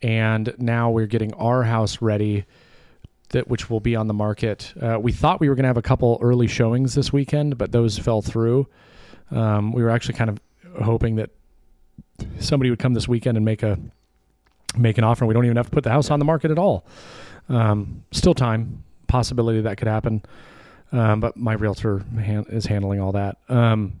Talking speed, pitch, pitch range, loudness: 200 wpm, 115 Hz, 105-125 Hz, -21 LUFS